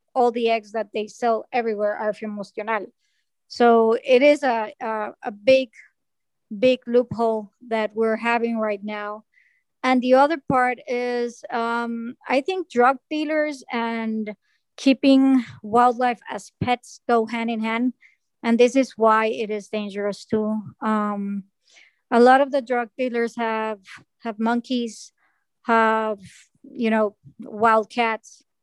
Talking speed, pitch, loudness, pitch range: 135 wpm, 235 Hz, -22 LUFS, 220-255 Hz